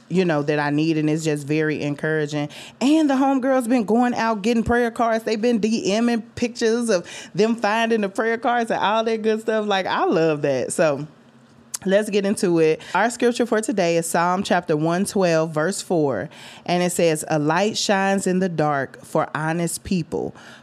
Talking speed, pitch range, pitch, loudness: 190 wpm, 155-225 Hz, 190 Hz, -21 LUFS